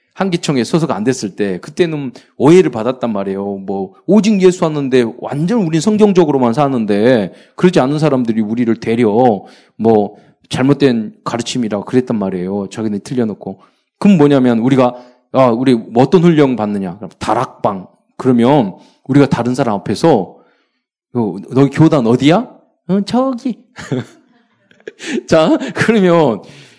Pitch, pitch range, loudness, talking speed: 135 Hz, 115-180 Hz, -14 LUFS, 290 characters per minute